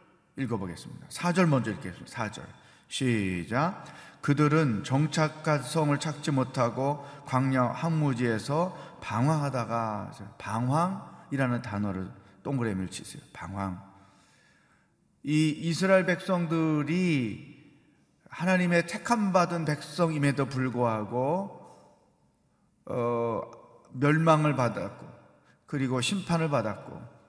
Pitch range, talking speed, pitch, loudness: 120-165 Hz, 225 characters per minute, 145 Hz, -28 LUFS